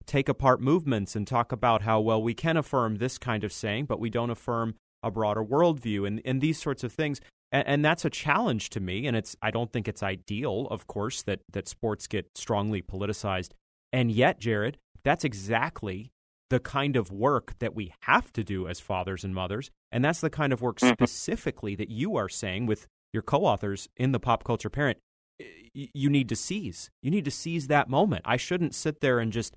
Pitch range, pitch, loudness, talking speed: 105-140 Hz, 115 Hz, -28 LUFS, 215 wpm